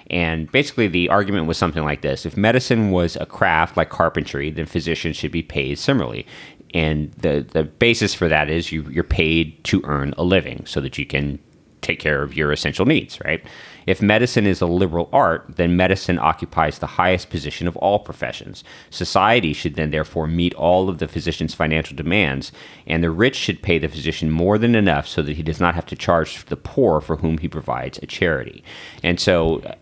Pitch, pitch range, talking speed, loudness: 85 Hz, 80-95 Hz, 200 wpm, -20 LUFS